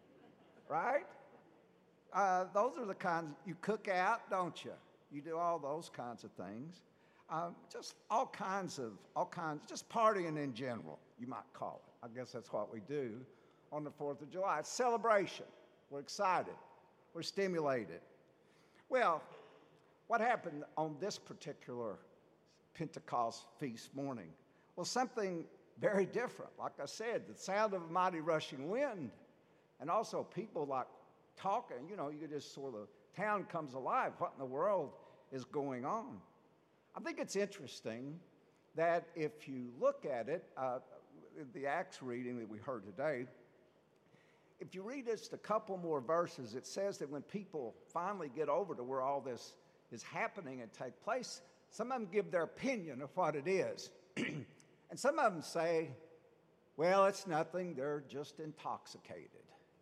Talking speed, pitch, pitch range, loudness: 160 wpm, 160 Hz, 140-190 Hz, -40 LUFS